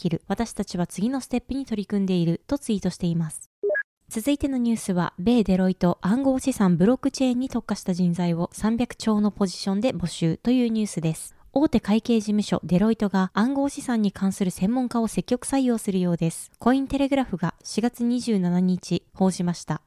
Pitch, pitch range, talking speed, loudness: 210 Hz, 180-245 Hz, 395 characters per minute, -24 LUFS